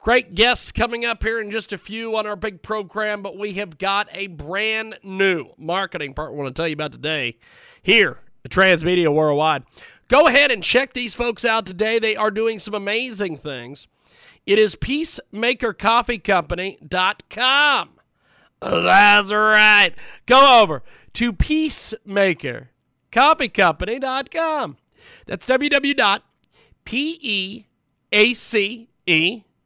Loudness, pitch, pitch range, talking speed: -18 LUFS, 210 Hz, 185-235 Hz, 125 wpm